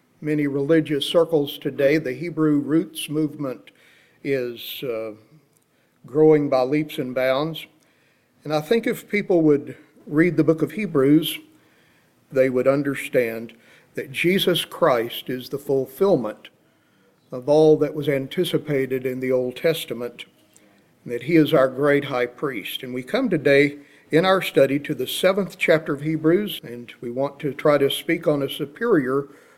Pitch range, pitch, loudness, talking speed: 135-160 Hz, 150 Hz, -21 LUFS, 150 wpm